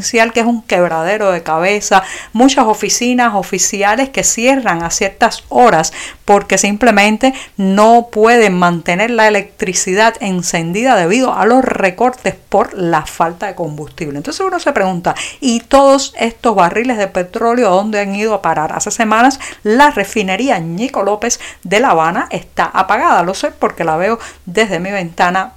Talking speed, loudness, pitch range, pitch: 155 wpm, -12 LUFS, 185-235 Hz, 205 Hz